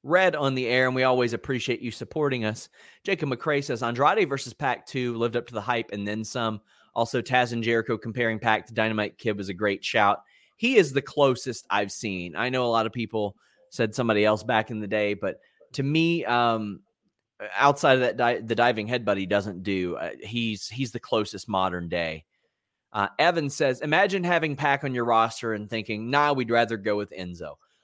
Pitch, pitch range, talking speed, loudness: 115 Hz, 105-130 Hz, 205 wpm, -25 LUFS